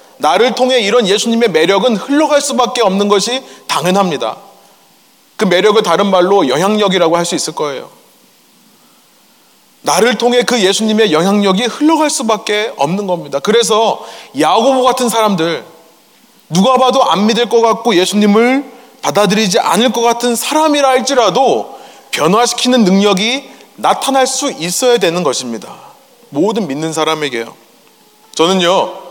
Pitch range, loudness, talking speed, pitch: 190-250 Hz, -12 LUFS, 305 characters per minute, 225 Hz